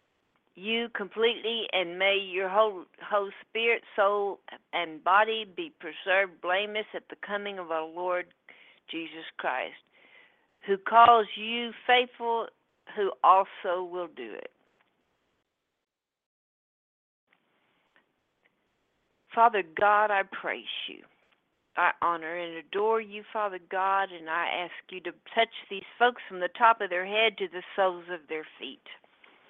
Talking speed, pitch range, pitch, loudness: 130 wpm, 180-225 Hz, 200 Hz, -28 LUFS